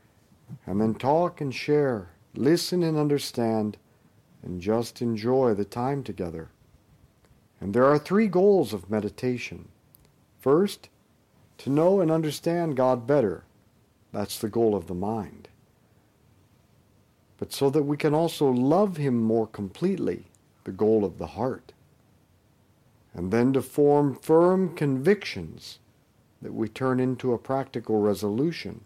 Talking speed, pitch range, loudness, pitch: 130 wpm, 105-145 Hz, -25 LUFS, 125 Hz